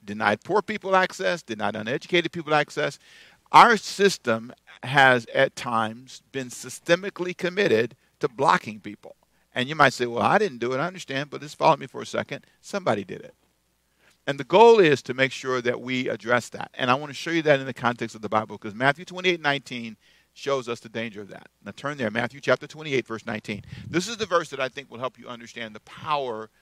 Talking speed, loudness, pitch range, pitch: 215 wpm, -24 LUFS, 115-155 Hz, 130 Hz